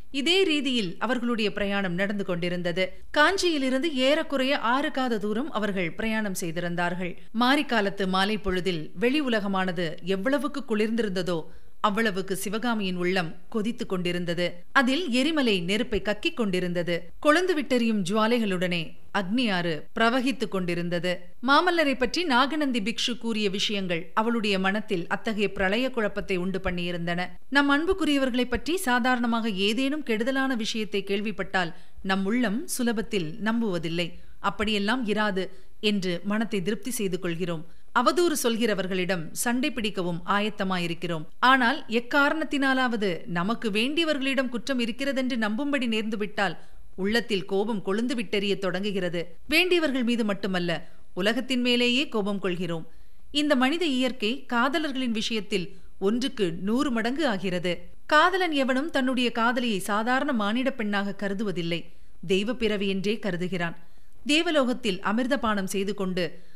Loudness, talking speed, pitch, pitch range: -26 LUFS, 105 wpm, 215 Hz, 190-255 Hz